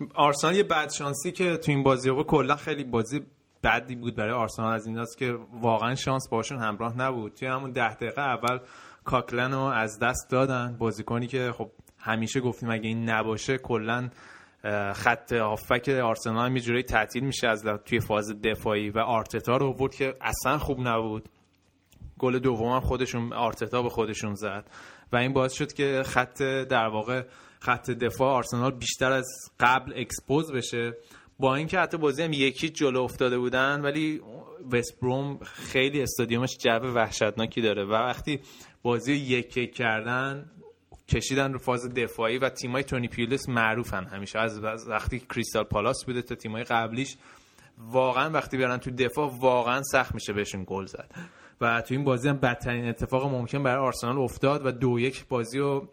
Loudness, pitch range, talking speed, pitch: -27 LUFS, 115-135 Hz, 165 wpm, 125 Hz